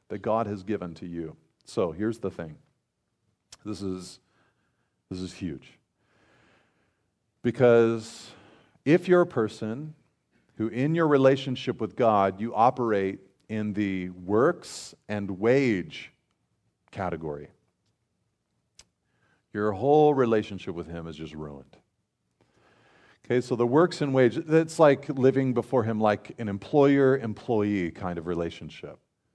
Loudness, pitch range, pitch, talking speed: -26 LUFS, 95-130 Hz, 110 Hz, 125 wpm